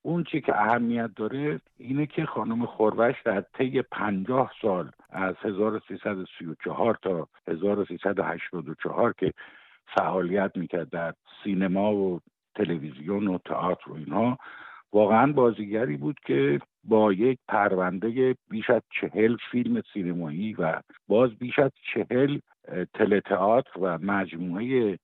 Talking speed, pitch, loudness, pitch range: 115 wpm, 105 Hz, -27 LUFS, 95-125 Hz